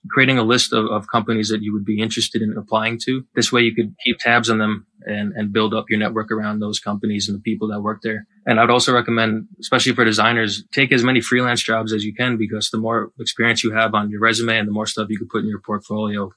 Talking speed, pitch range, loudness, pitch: 265 wpm, 105-115 Hz, -19 LUFS, 110 Hz